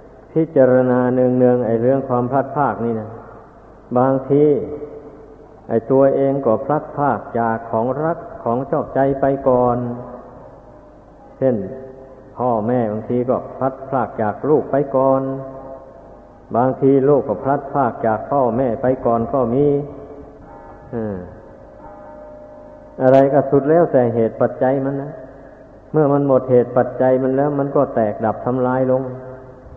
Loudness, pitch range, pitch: -17 LUFS, 120-140 Hz, 130 Hz